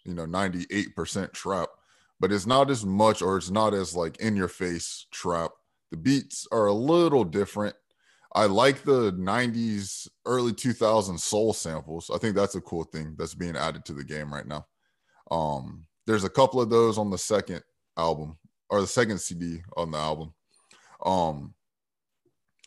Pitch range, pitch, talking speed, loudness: 80-110 Hz, 95 Hz, 170 wpm, -27 LUFS